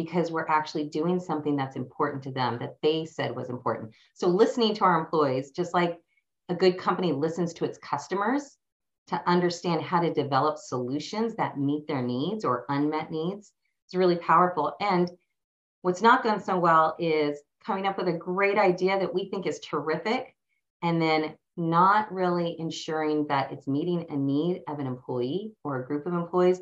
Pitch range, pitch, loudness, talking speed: 150-180 Hz, 165 Hz, -27 LUFS, 180 wpm